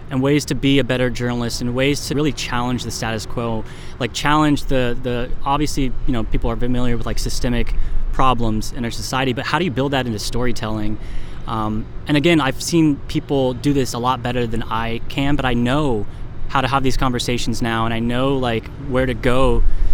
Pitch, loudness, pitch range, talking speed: 125 Hz, -20 LUFS, 115-135 Hz, 210 wpm